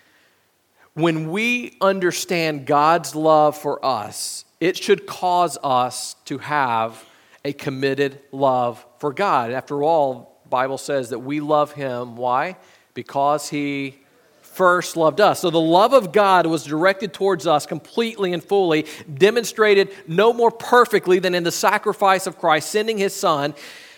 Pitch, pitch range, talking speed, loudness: 160 Hz, 140-195 Hz, 145 wpm, -19 LUFS